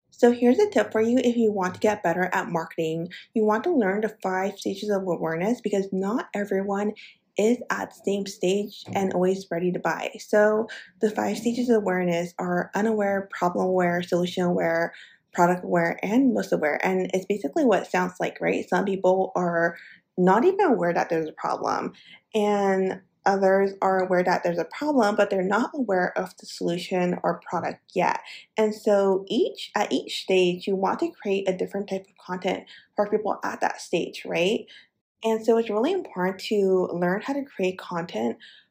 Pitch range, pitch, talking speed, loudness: 180-215 Hz, 195 Hz, 190 wpm, -25 LUFS